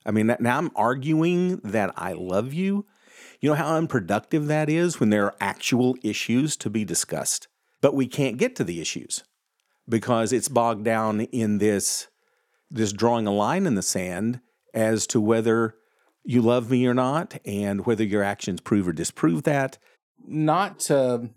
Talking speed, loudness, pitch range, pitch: 170 wpm, -24 LUFS, 110-145 Hz, 120 Hz